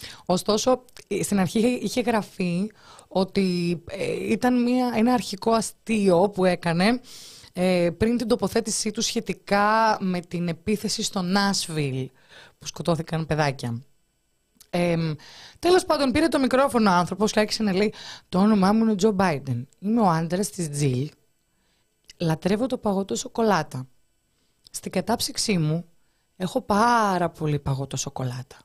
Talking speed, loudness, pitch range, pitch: 130 wpm, -24 LUFS, 165-220 Hz, 195 Hz